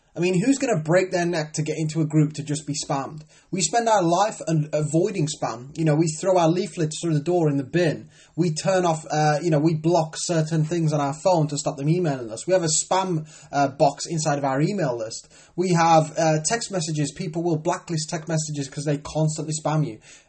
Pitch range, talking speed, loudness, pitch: 150-175 Hz, 235 wpm, -23 LUFS, 160 Hz